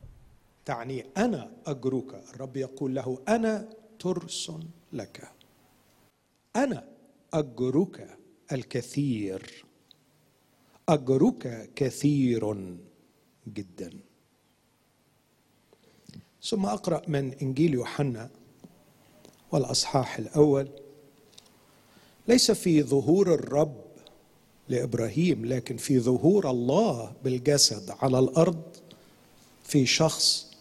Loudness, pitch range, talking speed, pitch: -27 LUFS, 130-160 Hz, 70 wpm, 140 Hz